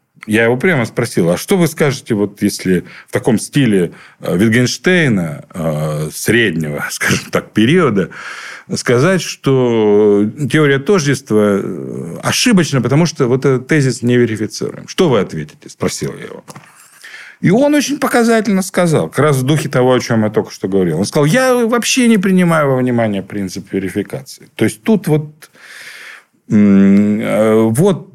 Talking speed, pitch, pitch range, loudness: 145 wpm, 130 Hz, 110-180 Hz, -14 LUFS